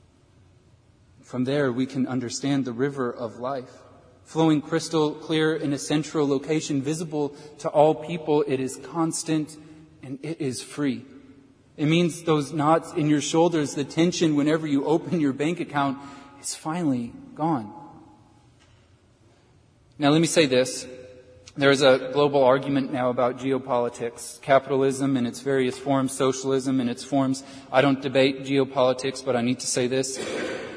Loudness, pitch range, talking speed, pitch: -24 LUFS, 125-150 Hz, 150 wpm, 135 Hz